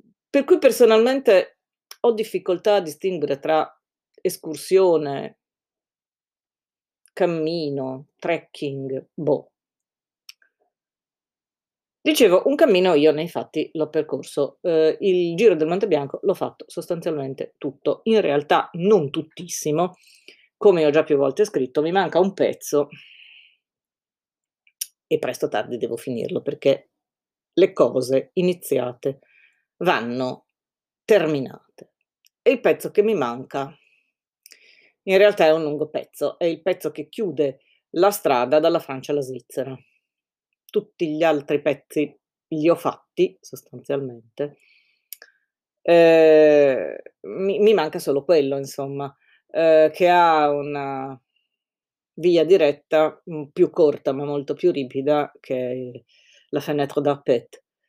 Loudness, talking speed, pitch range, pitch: -21 LUFS, 115 wpm, 145-190 Hz, 155 Hz